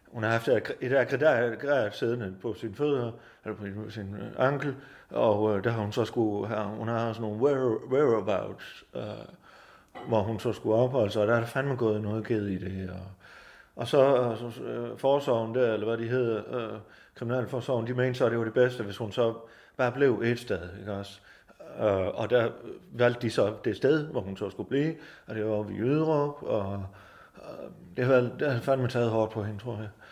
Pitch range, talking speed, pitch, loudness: 105-125 Hz, 215 wpm, 115 Hz, -29 LUFS